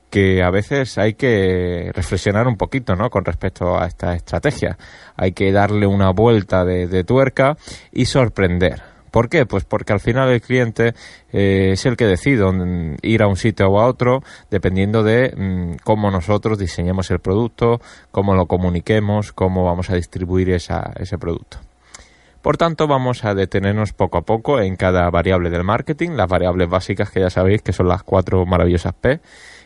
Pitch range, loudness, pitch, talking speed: 90-115 Hz, -17 LUFS, 95 Hz, 175 wpm